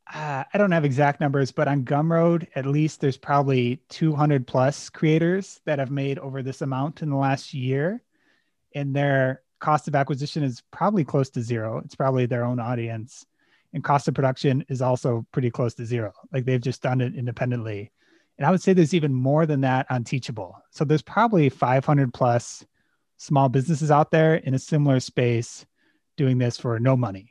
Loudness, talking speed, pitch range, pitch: -23 LUFS, 190 wpm, 130-155 Hz, 140 Hz